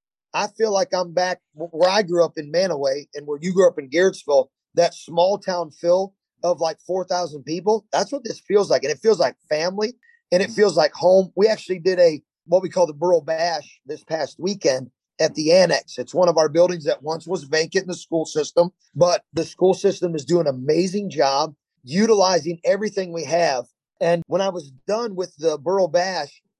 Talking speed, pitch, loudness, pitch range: 210 wpm, 175 Hz, -21 LUFS, 160-190 Hz